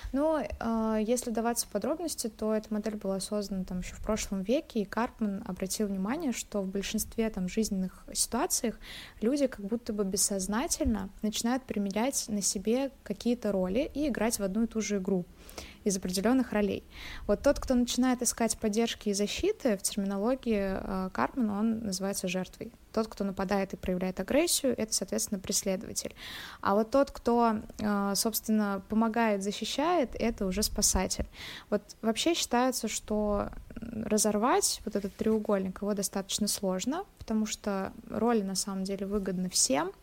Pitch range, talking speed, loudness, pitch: 200-235 Hz, 150 wpm, -30 LUFS, 215 Hz